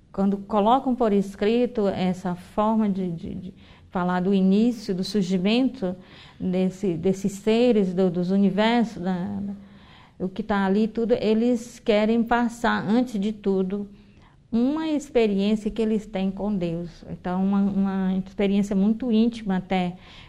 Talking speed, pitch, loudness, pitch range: 140 wpm, 200 Hz, -24 LUFS, 190-225 Hz